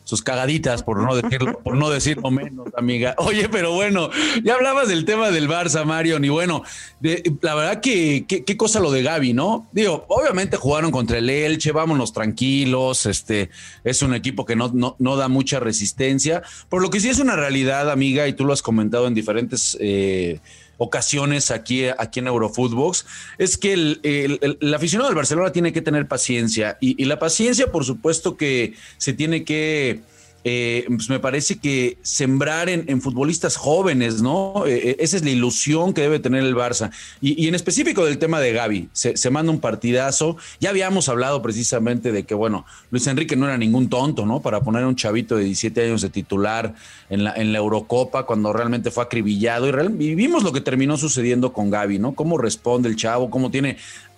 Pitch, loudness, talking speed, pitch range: 130 Hz, -20 LUFS, 200 wpm, 120-155 Hz